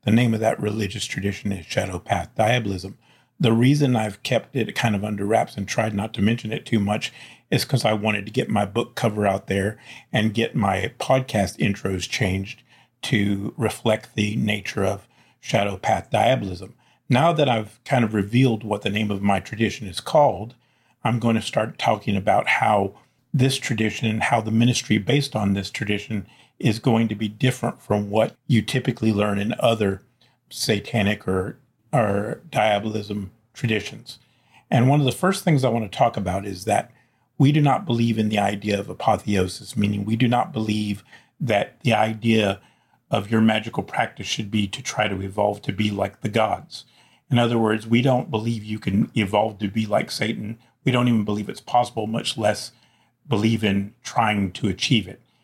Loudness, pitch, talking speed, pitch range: -22 LUFS, 110 Hz, 185 wpm, 105-120 Hz